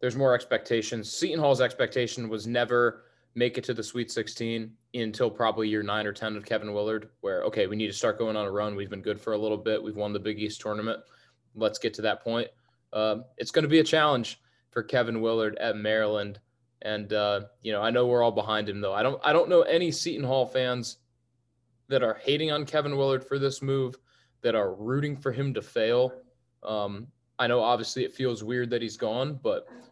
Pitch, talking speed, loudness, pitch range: 120 Hz, 220 wpm, -28 LUFS, 110-130 Hz